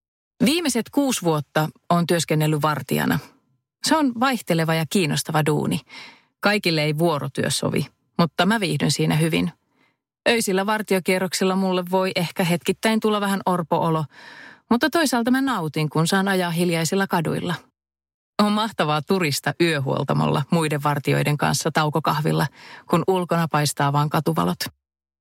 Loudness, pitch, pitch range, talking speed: -22 LUFS, 170 Hz, 150-195 Hz, 125 wpm